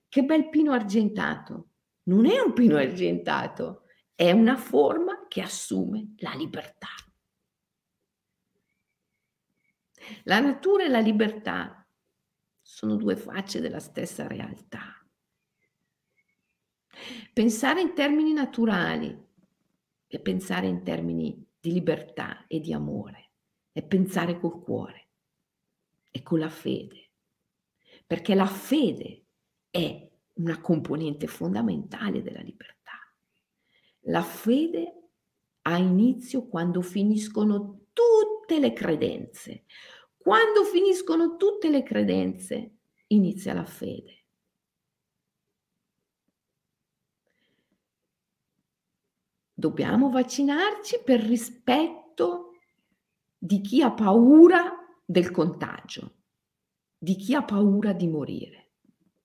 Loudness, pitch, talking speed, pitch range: -25 LUFS, 220 Hz, 90 wpm, 180-285 Hz